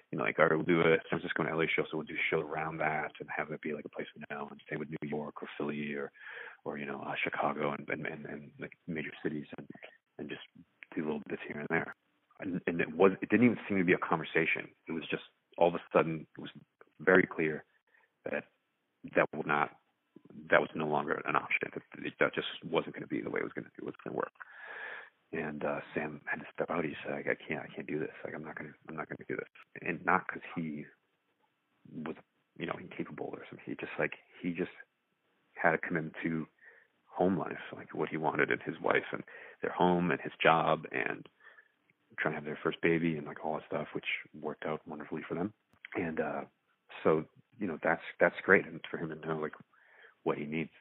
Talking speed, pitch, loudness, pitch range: 245 wpm, 75 Hz, -34 LUFS, 75-80 Hz